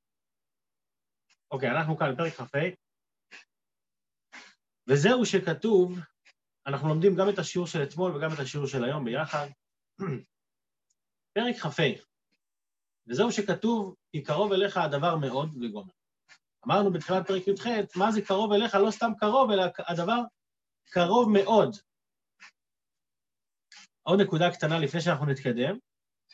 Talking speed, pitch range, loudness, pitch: 120 wpm, 140-200 Hz, -27 LUFS, 175 Hz